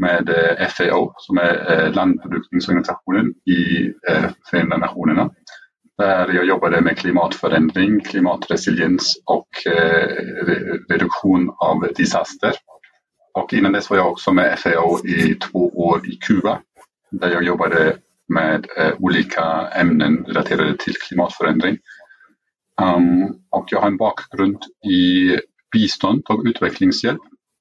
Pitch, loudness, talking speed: 95 Hz, -18 LUFS, 105 wpm